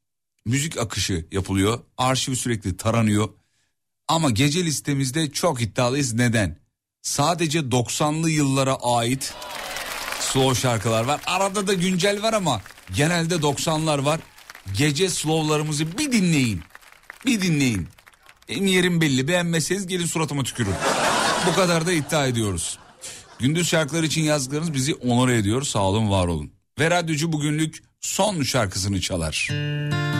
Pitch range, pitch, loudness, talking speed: 115-160 Hz, 140 Hz, -22 LUFS, 125 wpm